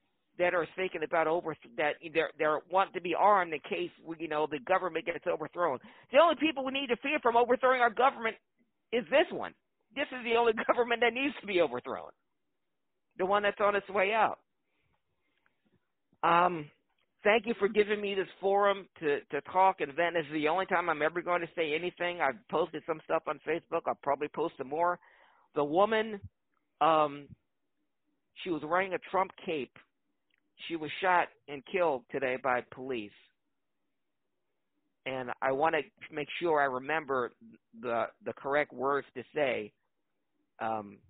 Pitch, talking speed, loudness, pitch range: 175 Hz, 170 wpm, -31 LUFS, 150-205 Hz